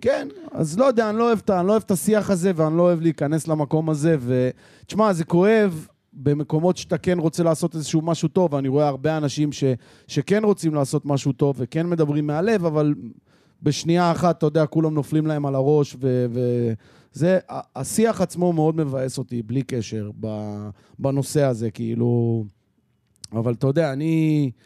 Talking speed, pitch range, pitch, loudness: 180 wpm, 135-170 Hz, 155 Hz, -22 LUFS